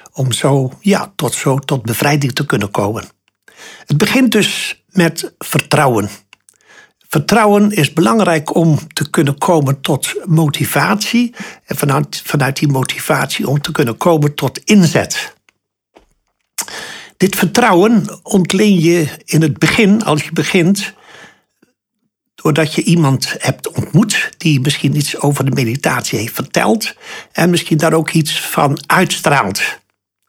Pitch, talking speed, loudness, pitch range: 160 Hz, 130 wpm, -14 LUFS, 145-195 Hz